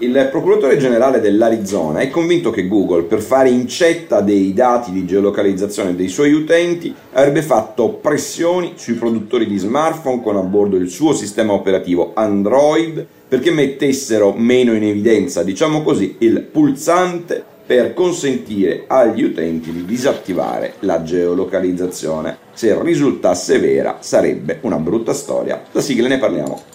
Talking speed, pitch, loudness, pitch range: 135 wpm, 115 Hz, -15 LUFS, 95-160 Hz